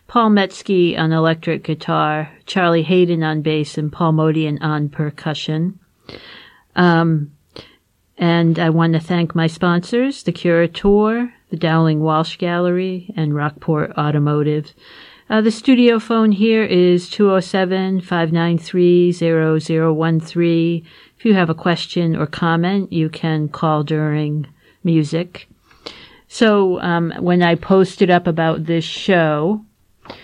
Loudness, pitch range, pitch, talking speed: -17 LUFS, 160-185 Hz, 170 Hz, 115 wpm